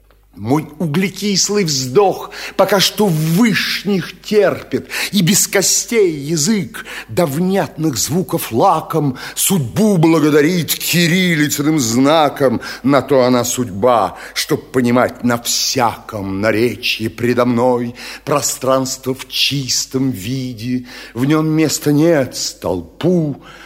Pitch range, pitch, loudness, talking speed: 125-180 Hz, 150 Hz, -15 LUFS, 100 wpm